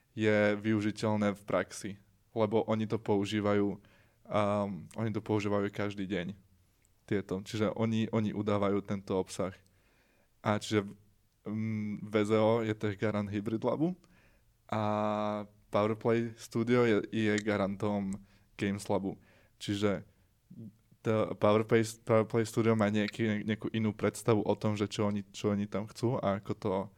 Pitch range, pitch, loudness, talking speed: 100-110 Hz, 105 Hz, -32 LUFS, 135 wpm